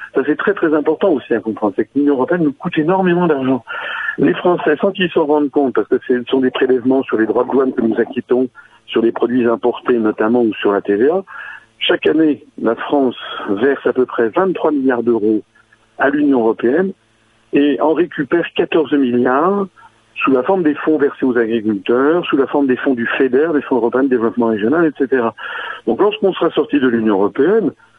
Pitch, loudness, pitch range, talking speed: 130 Hz, -15 LUFS, 115-155 Hz, 200 wpm